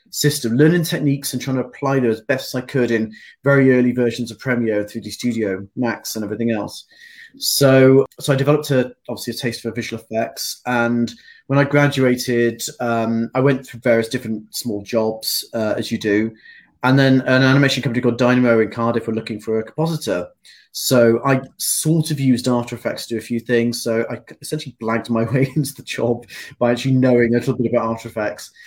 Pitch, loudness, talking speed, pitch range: 120 Hz, -19 LUFS, 200 wpm, 115-135 Hz